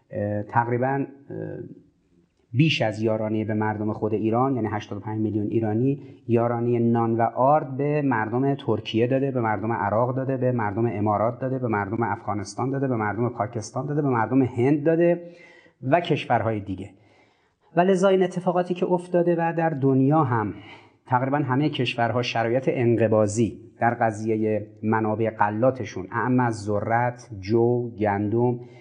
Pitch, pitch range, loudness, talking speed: 120 Hz, 110-135 Hz, -24 LUFS, 140 wpm